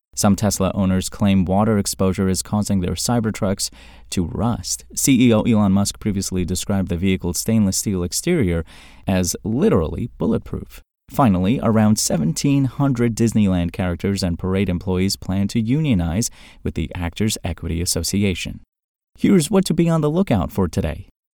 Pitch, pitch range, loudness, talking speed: 95 Hz, 90-110 Hz, -19 LUFS, 145 wpm